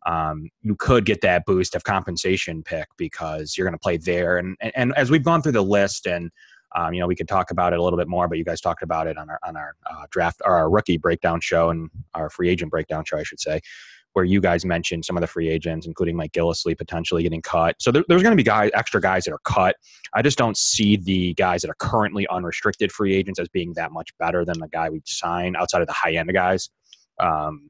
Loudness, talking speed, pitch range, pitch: -22 LUFS, 260 wpm, 85-100 Hz, 90 Hz